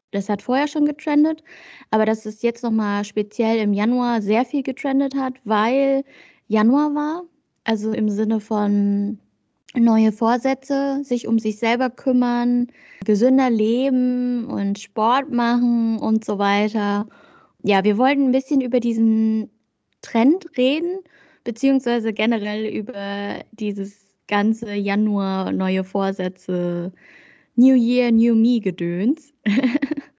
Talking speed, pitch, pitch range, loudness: 120 wpm, 230 Hz, 210-265 Hz, -20 LUFS